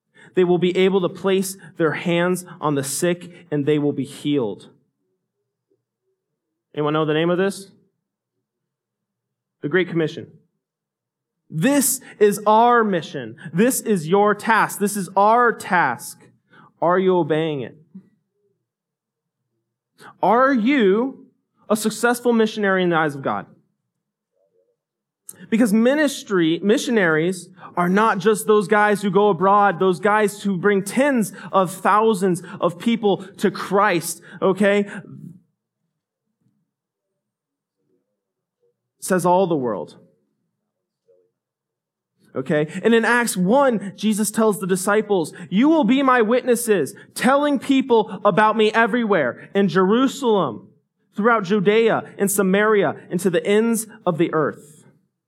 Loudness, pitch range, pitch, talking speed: -19 LUFS, 175-220 Hz, 200 Hz, 120 wpm